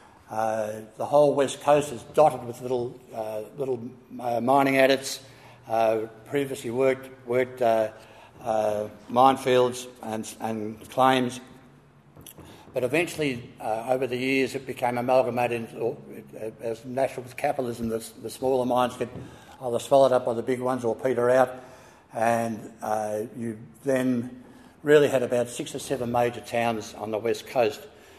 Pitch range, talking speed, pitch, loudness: 115-130 Hz, 150 wpm, 125 Hz, -26 LUFS